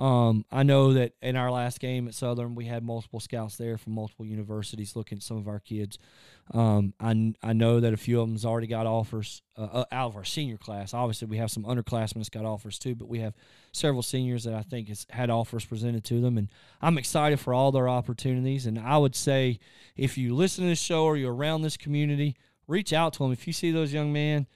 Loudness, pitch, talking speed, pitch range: -28 LUFS, 120 Hz, 235 wpm, 110-135 Hz